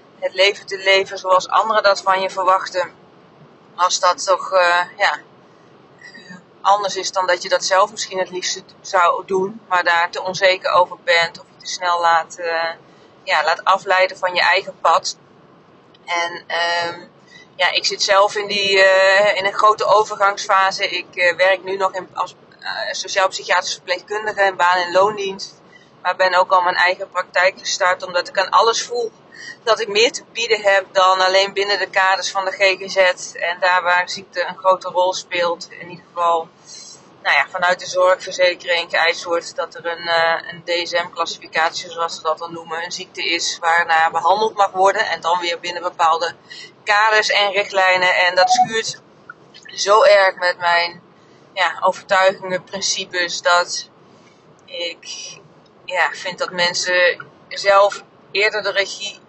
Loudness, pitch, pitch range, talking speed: -17 LUFS, 185 Hz, 175-195 Hz, 165 wpm